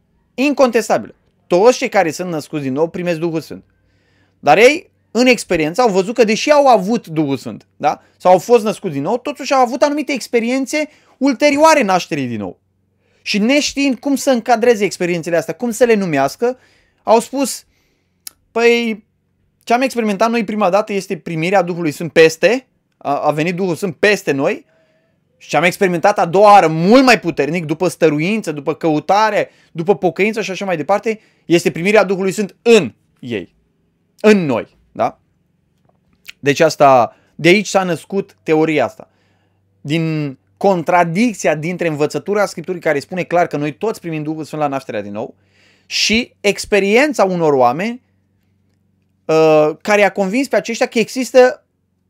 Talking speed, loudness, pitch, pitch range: 155 wpm, -15 LUFS, 185 Hz, 155-230 Hz